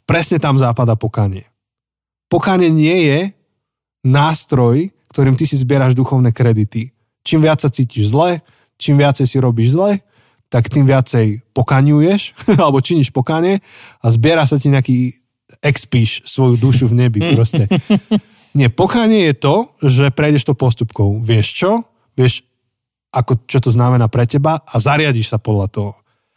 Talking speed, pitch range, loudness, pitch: 145 wpm, 120-150 Hz, -14 LUFS, 130 Hz